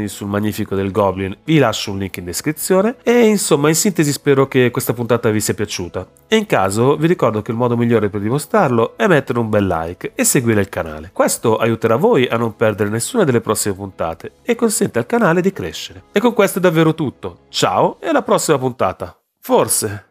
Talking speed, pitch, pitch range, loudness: 205 wpm, 120 Hz, 105-160 Hz, -16 LUFS